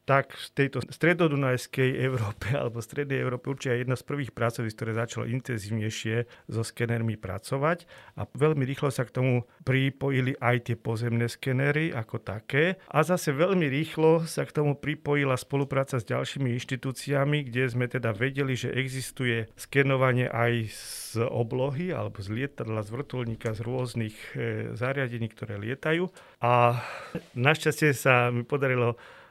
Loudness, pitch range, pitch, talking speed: -28 LUFS, 120-140 Hz, 130 Hz, 140 wpm